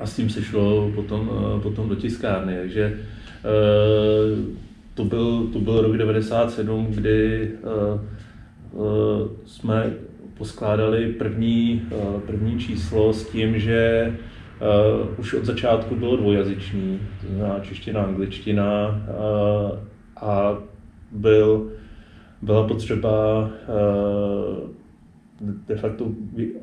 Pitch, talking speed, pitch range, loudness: 110 Hz, 90 wpm, 105-110 Hz, -22 LUFS